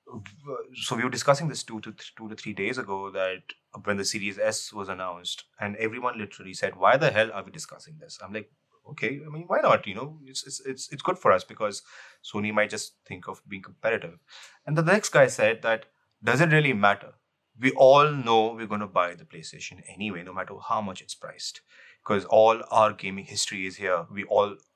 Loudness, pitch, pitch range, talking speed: -25 LUFS, 110 Hz, 105-140 Hz, 210 wpm